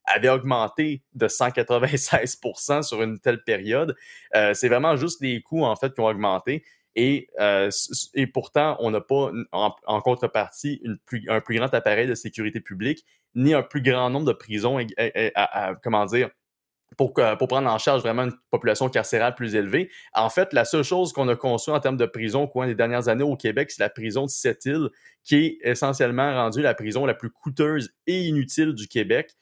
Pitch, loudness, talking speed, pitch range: 125 Hz, -23 LUFS, 205 wpm, 115-145 Hz